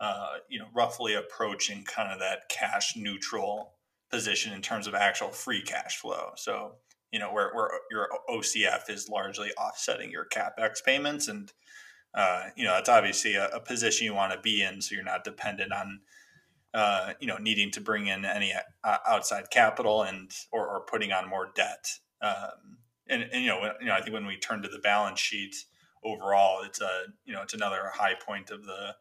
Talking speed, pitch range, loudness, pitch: 200 wpm, 100-110 Hz, -29 LUFS, 105 Hz